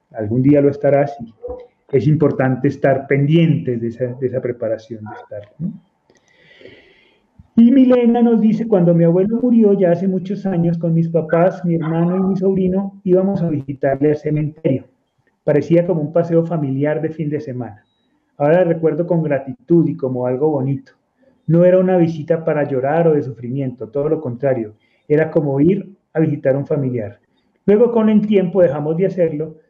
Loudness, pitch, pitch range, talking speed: -16 LUFS, 160 Hz, 140-185 Hz, 170 wpm